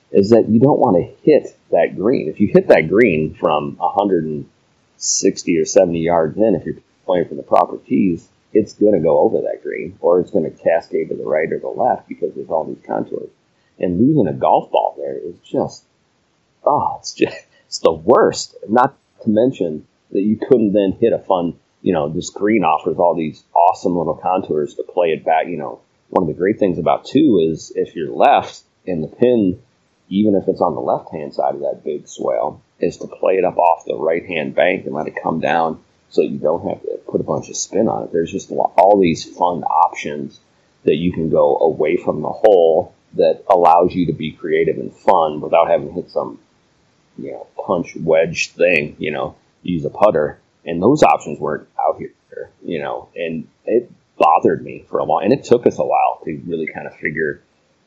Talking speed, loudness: 215 wpm, -17 LUFS